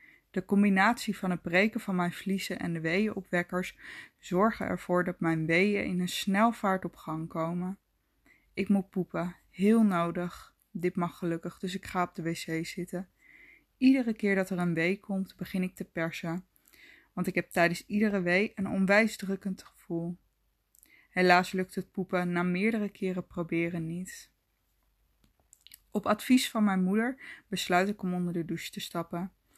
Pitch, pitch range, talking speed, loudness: 185 Hz, 175-200 Hz, 160 wpm, -30 LUFS